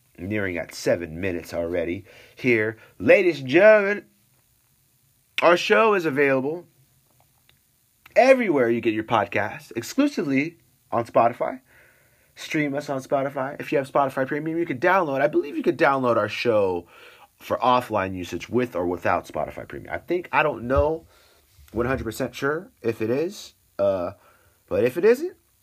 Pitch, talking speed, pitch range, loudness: 135 Hz, 145 wpm, 120-175 Hz, -23 LUFS